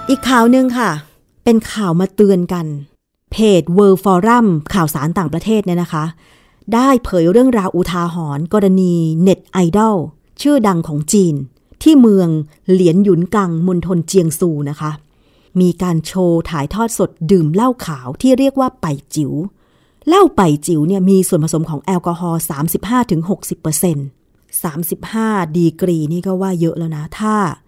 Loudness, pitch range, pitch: -14 LUFS, 160-205 Hz, 180 Hz